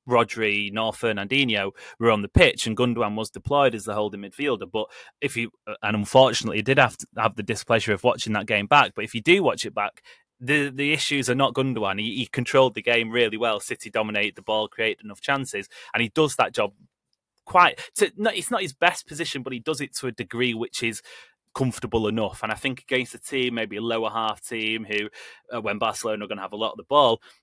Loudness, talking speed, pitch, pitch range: -23 LUFS, 230 wpm, 115 Hz, 110-135 Hz